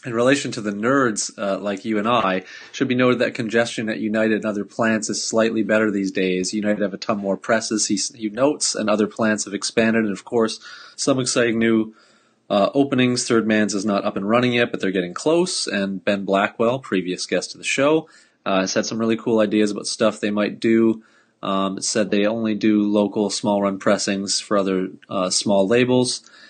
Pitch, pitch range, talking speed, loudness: 110 Hz, 100-115 Hz, 210 wpm, -20 LUFS